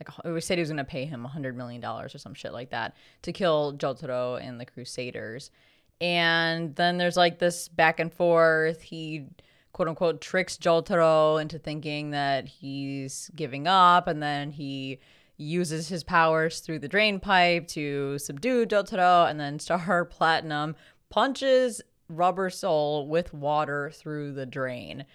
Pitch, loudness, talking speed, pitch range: 160 Hz, -26 LUFS, 155 wpm, 145-175 Hz